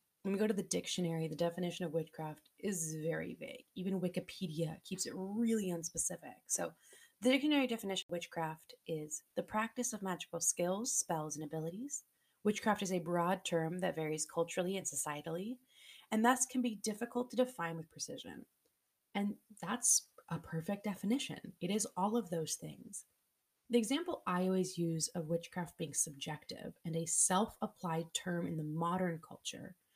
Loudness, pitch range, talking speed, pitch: -38 LUFS, 165-215 Hz, 165 wpm, 180 Hz